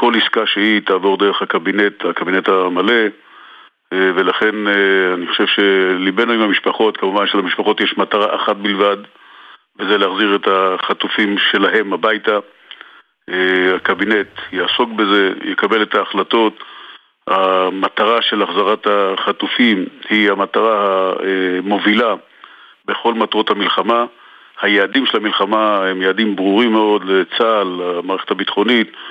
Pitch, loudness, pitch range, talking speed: 100 Hz, -15 LUFS, 95-105 Hz, 105 wpm